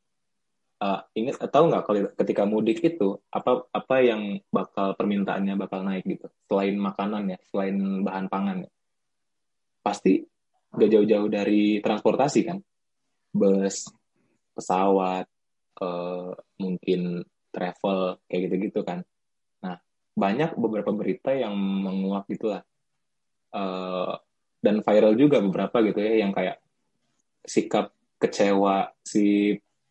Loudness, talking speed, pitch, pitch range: -25 LUFS, 110 wpm, 100 Hz, 95-105 Hz